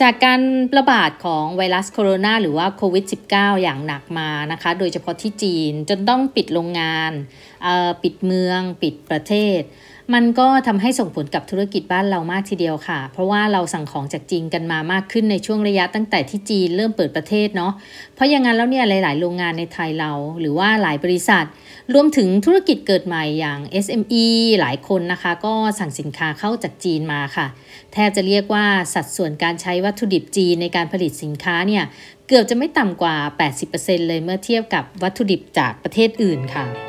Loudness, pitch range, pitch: -18 LUFS, 165-210 Hz, 185 Hz